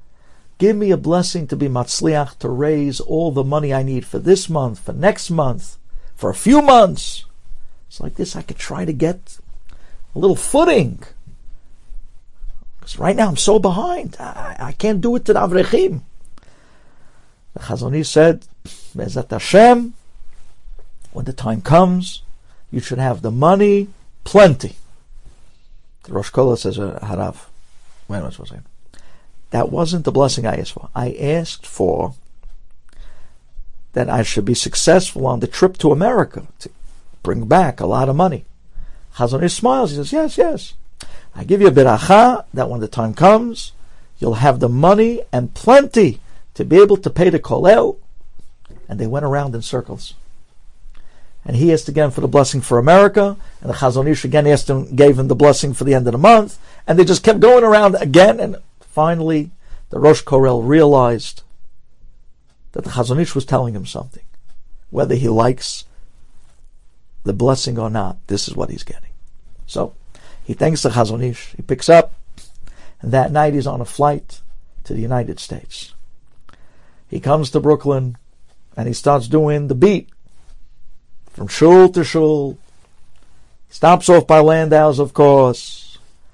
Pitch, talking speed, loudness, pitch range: 145 Hz, 160 wpm, -14 LUFS, 120-175 Hz